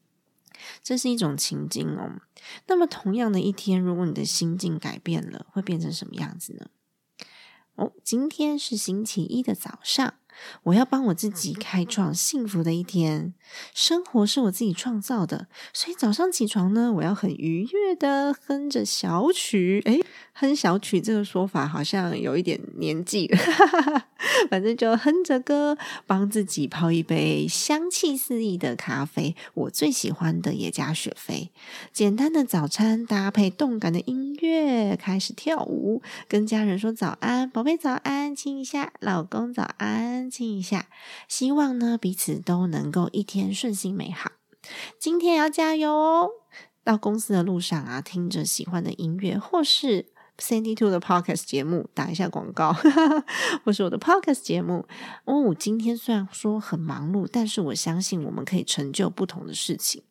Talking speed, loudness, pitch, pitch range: 260 characters per minute, -25 LUFS, 215 Hz, 180-270 Hz